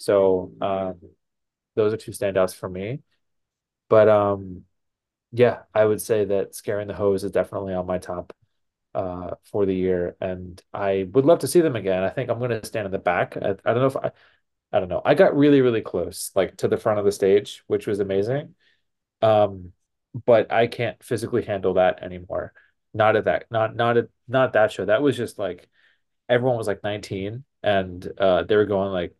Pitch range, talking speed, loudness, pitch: 95-120 Hz, 200 wpm, -22 LUFS, 100 Hz